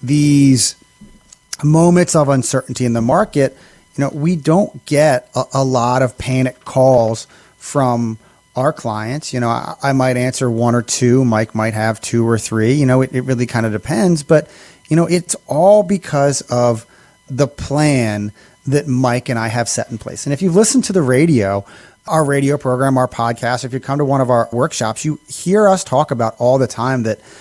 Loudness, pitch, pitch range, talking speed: -15 LUFS, 130 Hz, 120-150 Hz, 195 wpm